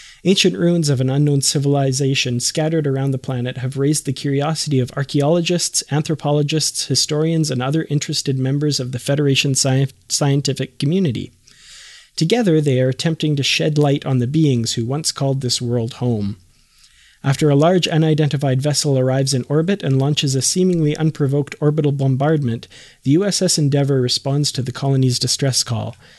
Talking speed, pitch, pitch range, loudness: 155 wpm, 140 Hz, 130-155 Hz, -18 LUFS